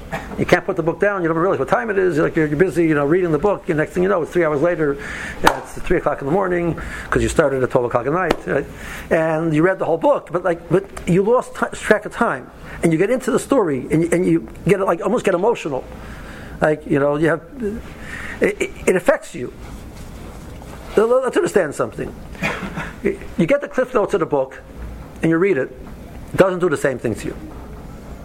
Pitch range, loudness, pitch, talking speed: 160-200 Hz, -19 LUFS, 175 Hz, 230 wpm